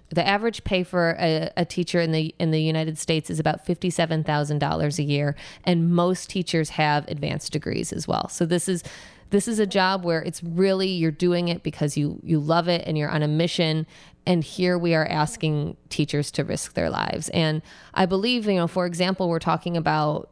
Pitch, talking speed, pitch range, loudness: 170 Hz, 215 wpm, 155-180 Hz, -24 LUFS